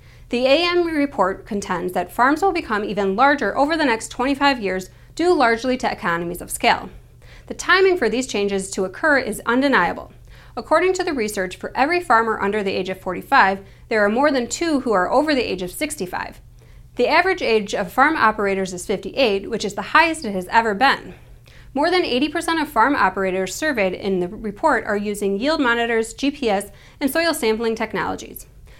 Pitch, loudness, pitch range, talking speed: 225 Hz, -19 LUFS, 200-290 Hz, 185 wpm